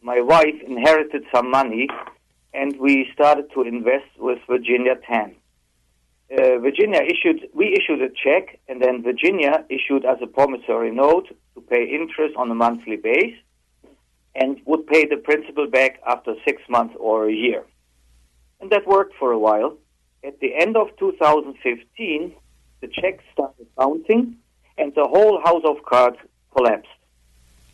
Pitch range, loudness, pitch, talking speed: 110-160 Hz, -19 LUFS, 130 Hz, 150 wpm